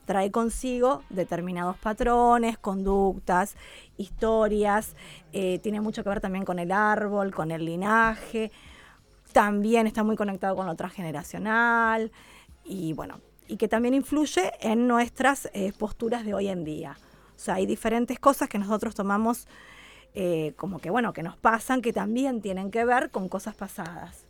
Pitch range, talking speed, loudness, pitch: 190-230 Hz, 155 wpm, -26 LUFS, 210 Hz